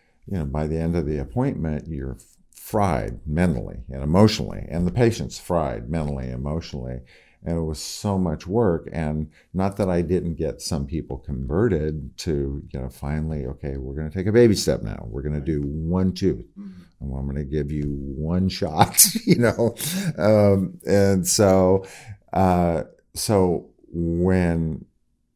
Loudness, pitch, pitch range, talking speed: -23 LUFS, 85 Hz, 75-95 Hz, 165 wpm